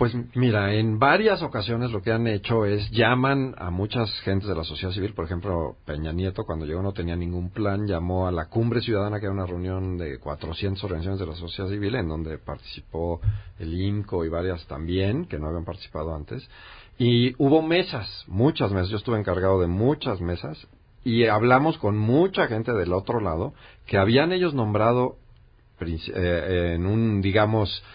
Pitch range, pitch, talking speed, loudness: 90-120 Hz, 100 Hz, 180 wpm, -25 LUFS